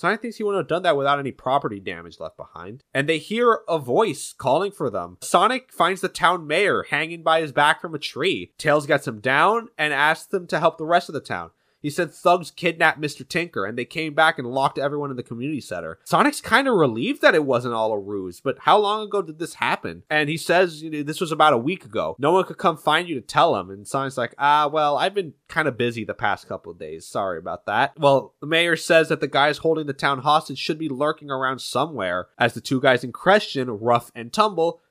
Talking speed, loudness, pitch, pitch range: 250 wpm, -21 LUFS, 150 Hz, 135-170 Hz